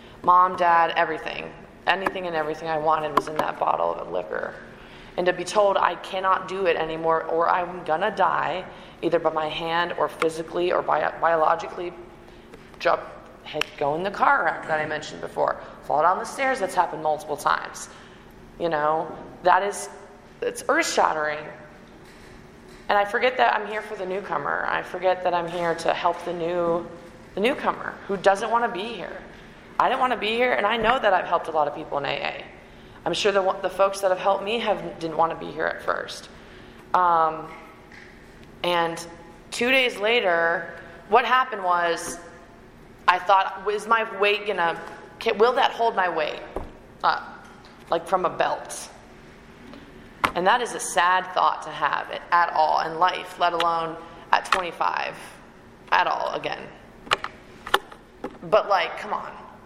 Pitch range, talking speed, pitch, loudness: 165-200 Hz, 170 wpm, 175 Hz, -23 LUFS